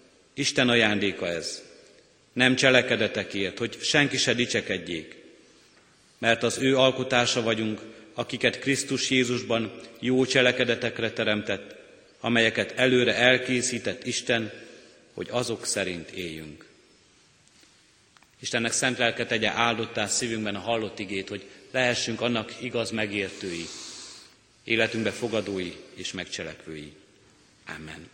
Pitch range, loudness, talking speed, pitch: 105-125 Hz, -25 LUFS, 100 wpm, 115 Hz